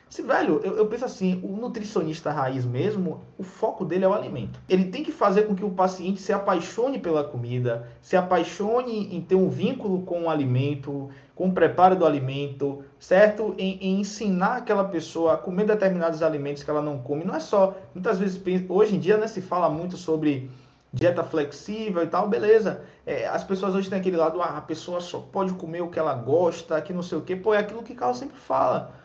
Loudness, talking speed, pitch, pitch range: -25 LUFS, 215 wpm, 180 Hz, 155-205 Hz